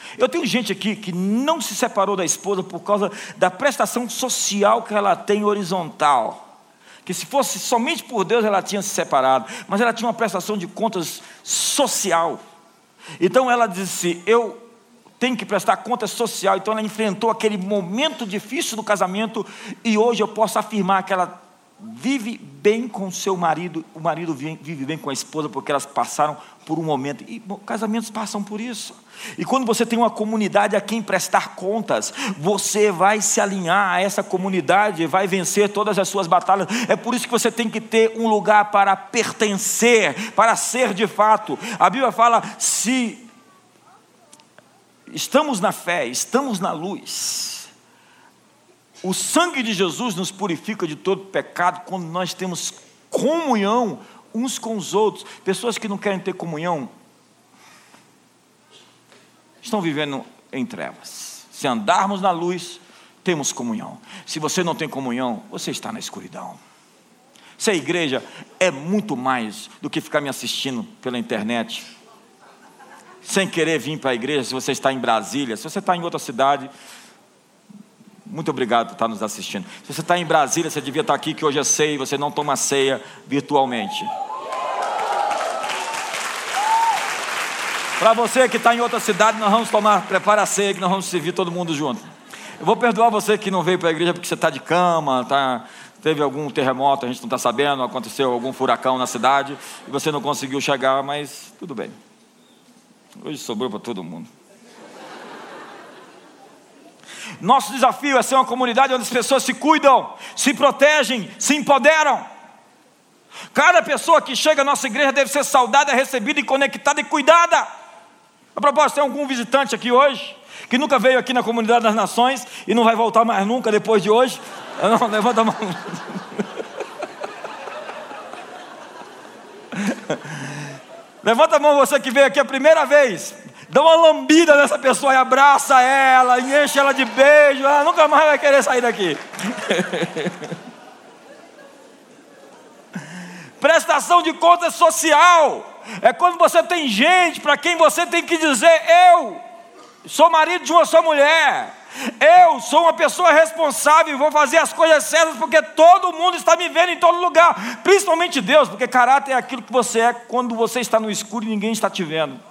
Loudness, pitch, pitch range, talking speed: -18 LUFS, 220 Hz, 185-265 Hz, 165 wpm